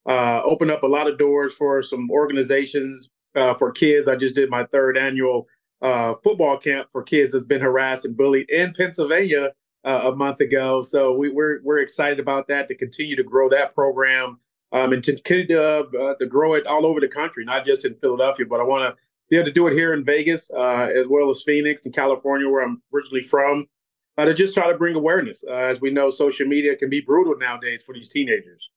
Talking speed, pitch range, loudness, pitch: 225 wpm, 130-150 Hz, -20 LUFS, 140 Hz